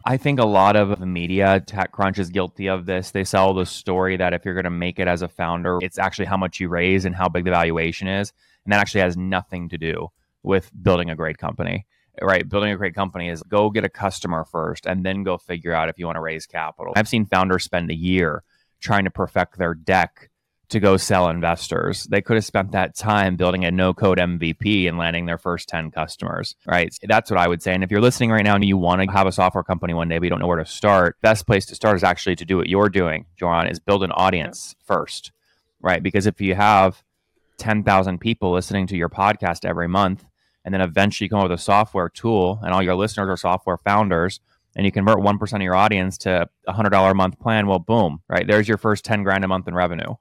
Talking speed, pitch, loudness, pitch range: 245 wpm, 95 Hz, -20 LUFS, 90-100 Hz